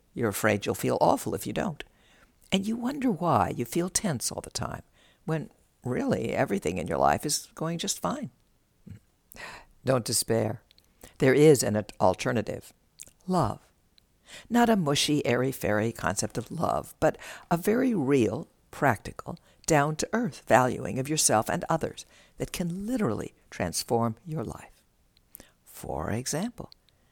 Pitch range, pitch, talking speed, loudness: 115-180 Hz, 145 Hz, 140 wpm, -27 LUFS